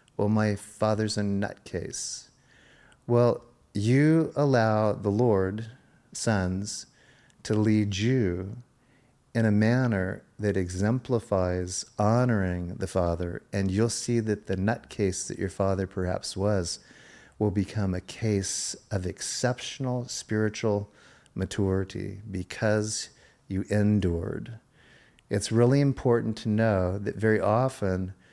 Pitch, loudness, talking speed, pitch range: 105 Hz, -27 LUFS, 110 wpm, 95-115 Hz